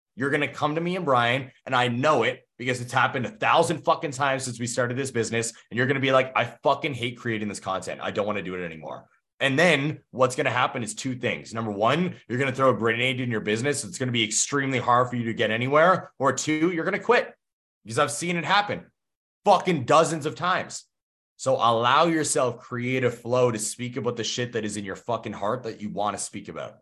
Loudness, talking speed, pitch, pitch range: -24 LUFS, 250 wpm, 125 Hz, 115-145 Hz